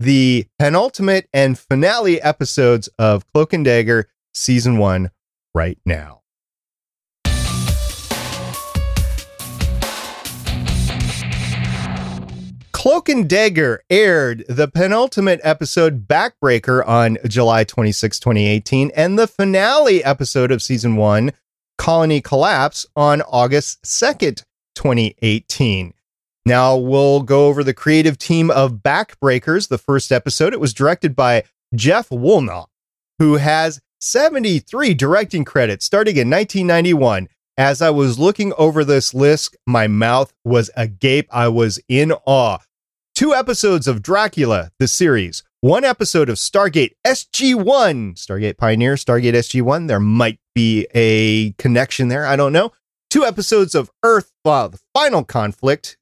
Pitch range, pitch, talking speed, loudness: 110-155 Hz, 135 Hz, 125 wpm, -16 LUFS